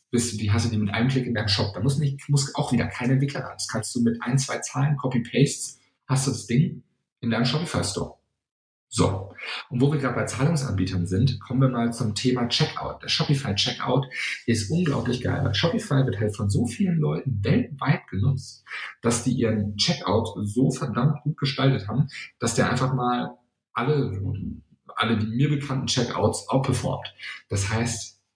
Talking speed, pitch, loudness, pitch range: 180 wpm, 125 Hz, -25 LUFS, 110-135 Hz